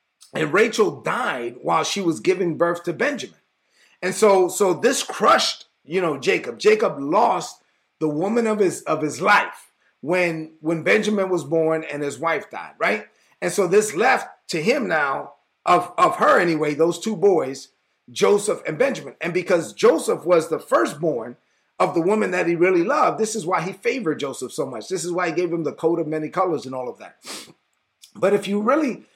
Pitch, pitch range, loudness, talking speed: 180 Hz, 160-205 Hz, -21 LUFS, 195 wpm